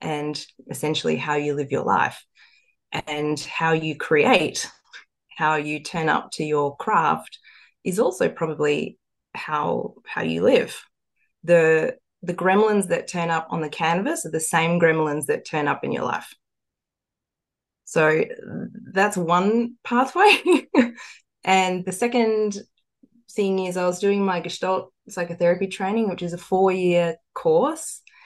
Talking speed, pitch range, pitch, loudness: 140 wpm, 160-210 Hz, 175 Hz, -22 LUFS